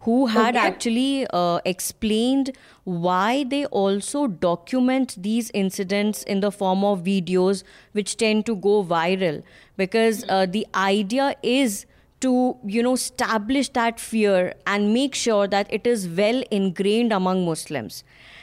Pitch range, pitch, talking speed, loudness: 190-240 Hz, 210 Hz, 135 wpm, -22 LUFS